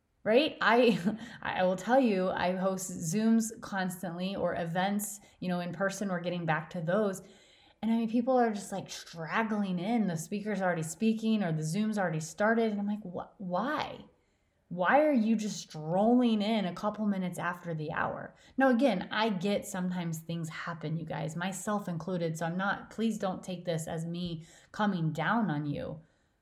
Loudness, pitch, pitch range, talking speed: -31 LUFS, 190 Hz, 175-215 Hz, 180 wpm